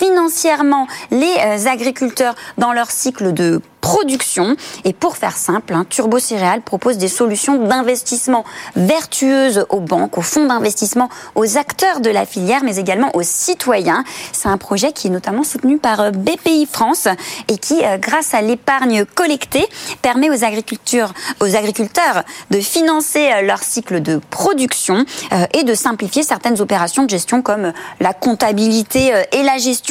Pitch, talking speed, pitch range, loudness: 245 Hz, 145 wpm, 210-280 Hz, -15 LUFS